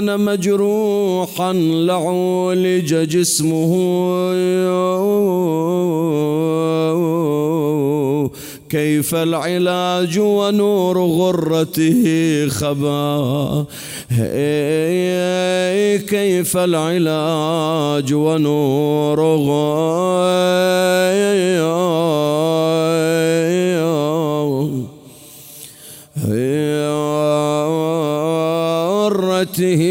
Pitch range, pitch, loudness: 150-180 Hz, 160 Hz, -17 LUFS